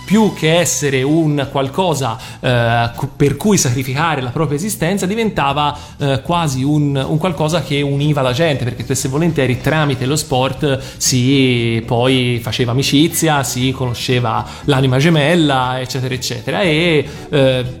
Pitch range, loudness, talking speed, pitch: 130-155 Hz, -15 LUFS, 135 wpm, 140 Hz